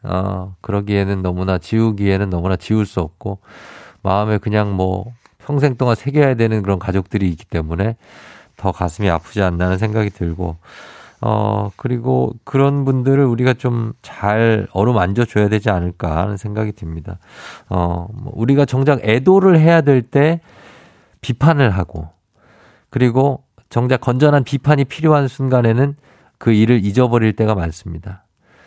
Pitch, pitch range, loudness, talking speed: 110 Hz, 95-130 Hz, -17 LUFS, 305 characters per minute